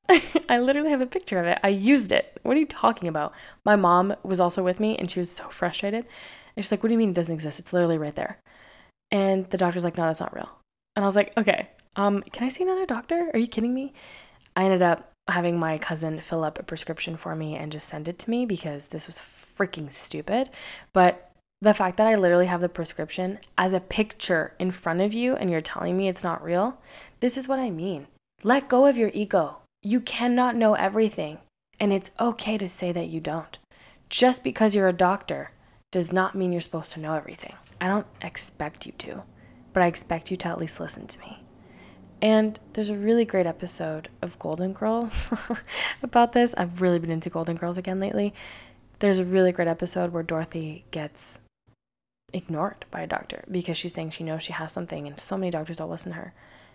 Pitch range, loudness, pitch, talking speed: 170-215 Hz, -25 LUFS, 185 Hz, 220 wpm